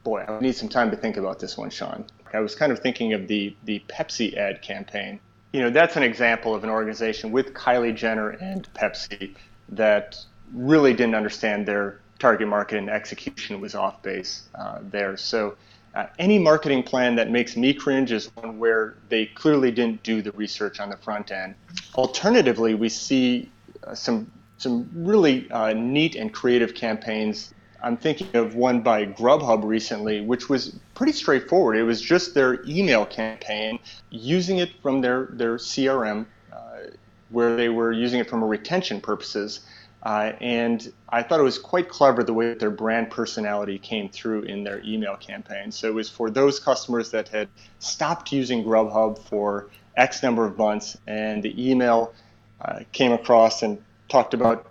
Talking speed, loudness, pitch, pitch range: 175 wpm, -23 LUFS, 115 Hz, 105-130 Hz